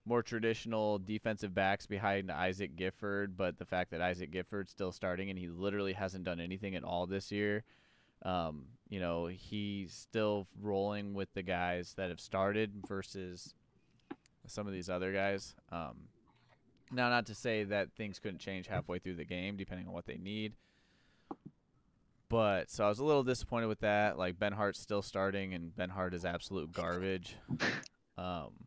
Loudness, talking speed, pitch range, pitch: -38 LUFS, 170 wpm, 90-105 Hz, 95 Hz